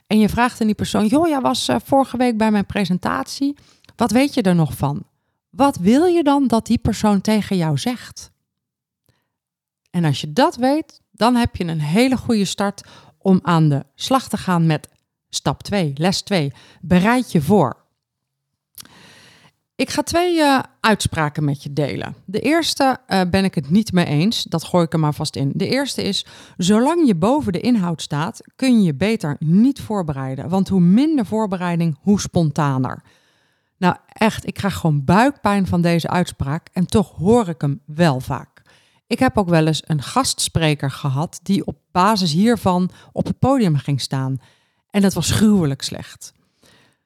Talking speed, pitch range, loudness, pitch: 180 wpm, 155-225 Hz, -18 LUFS, 190 Hz